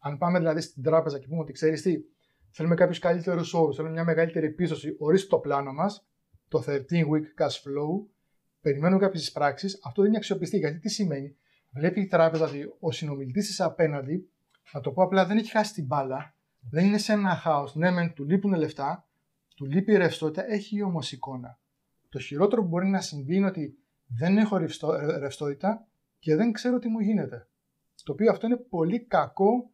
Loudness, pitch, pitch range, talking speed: -27 LUFS, 165 Hz, 145-195 Hz, 190 wpm